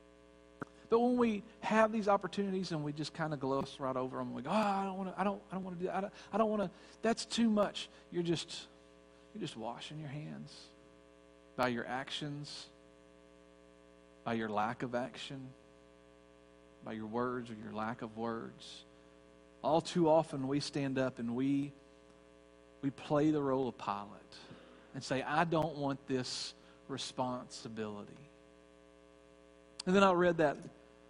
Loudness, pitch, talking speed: -36 LUFS, 125 Hz, 170 wpm